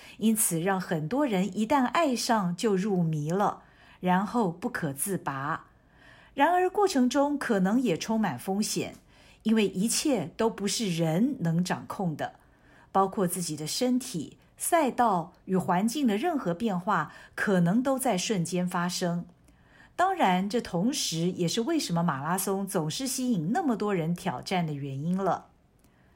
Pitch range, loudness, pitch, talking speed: 175-240 Hz, -28 LUFS, 195 Hz, 220 characters per minute